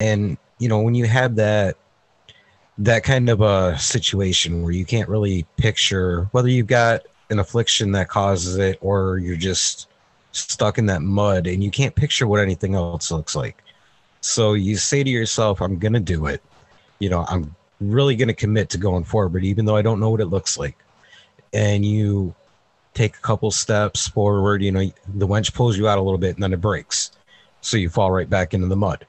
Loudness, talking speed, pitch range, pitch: -20 LUFS, 200 wpm, 95-110 Hz, 100 Hz